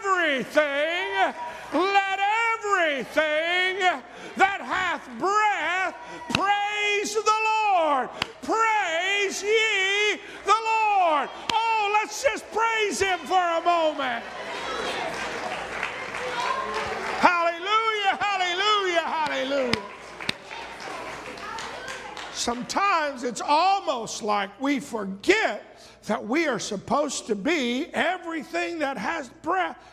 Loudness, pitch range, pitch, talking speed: -24 LUFS, 290-405 Hz, 350 Hz, 80 wpm